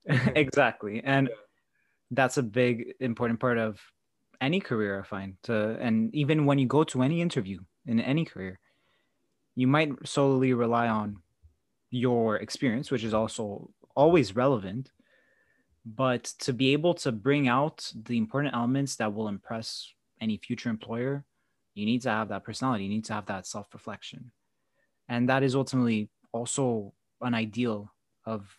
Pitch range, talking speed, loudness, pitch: 110-135 Hz, 155 wpm, -28 LUFS, 120 Hz